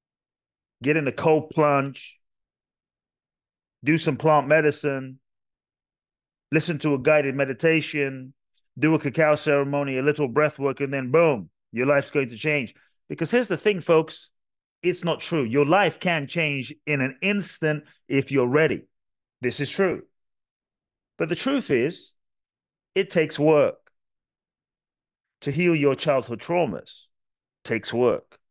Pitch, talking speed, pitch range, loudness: 150 Hz, 135 wpm, 135-165 Hz, -23 LUFS